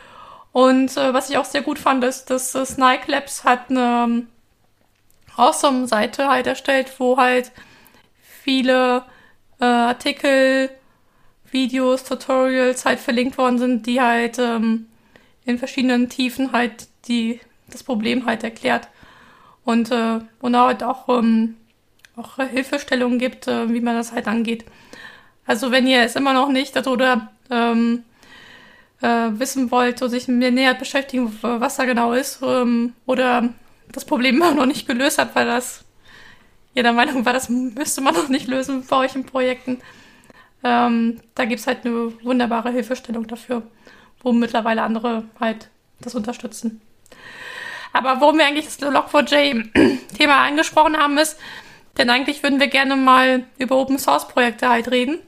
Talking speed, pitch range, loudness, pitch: 150 wpm, 240-265 Hz, -19 LUFS, 255 Hz